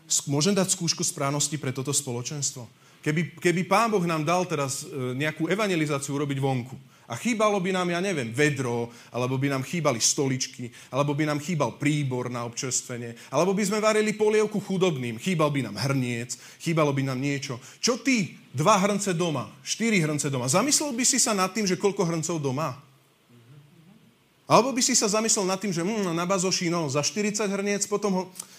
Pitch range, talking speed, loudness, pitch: 135-195 Hz, 180 wpm, -25 LUFS, 155 Hz